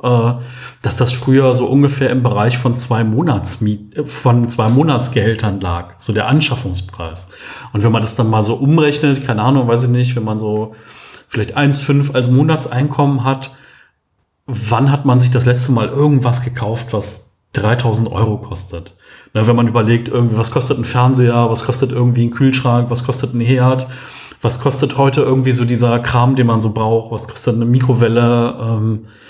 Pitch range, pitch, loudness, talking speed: 115-130 Hz, 120 Hz, -14 LUFS, 175 wpm